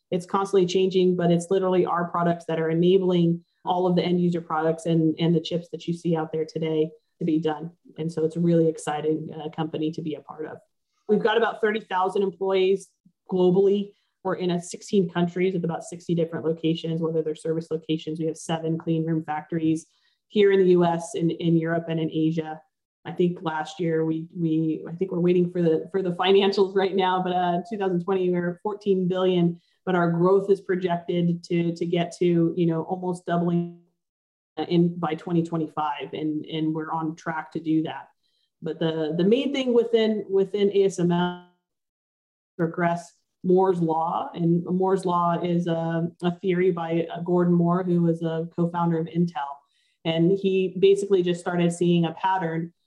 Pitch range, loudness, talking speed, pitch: 160-185 Hz, -24 LUFS, 185 wpm, 170 Hz